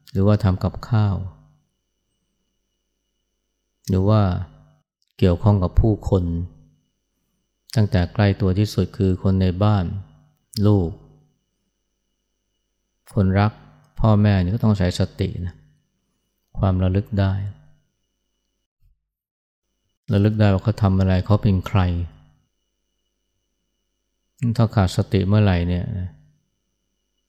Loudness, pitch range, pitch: -20 LUFS, 90-105 Hz, 95 Hz